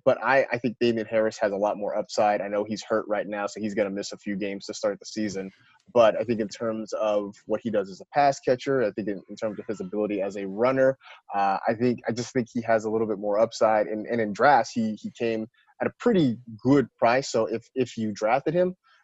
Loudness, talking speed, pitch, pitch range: -26 LUFS, 265 wpm, 110 Hz, 105-120 Hz